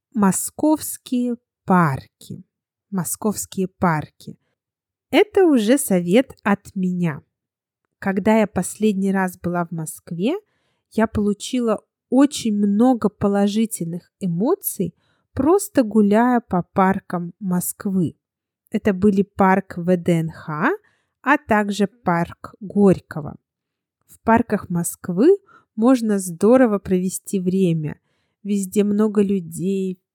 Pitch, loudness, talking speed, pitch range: 200 Hz, -20 LUFS, 90 wpm, 180-225 Hz